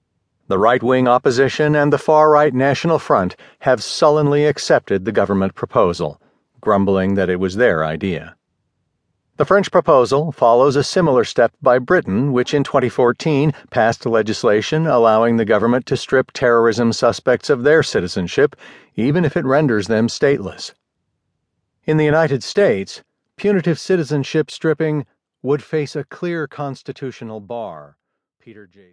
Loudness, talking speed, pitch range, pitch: -16 LUFS, 140 wpm, 115-150 Hz, 135 Hz